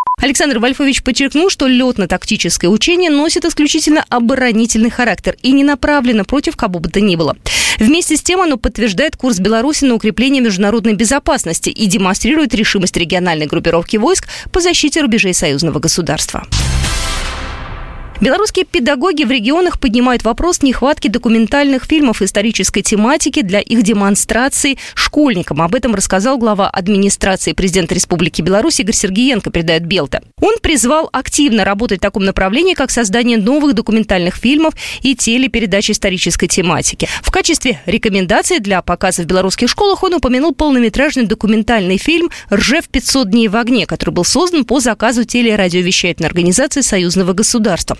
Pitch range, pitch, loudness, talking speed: 195-280 Hz, 230 Hz, -12 LUFS, 140 wpm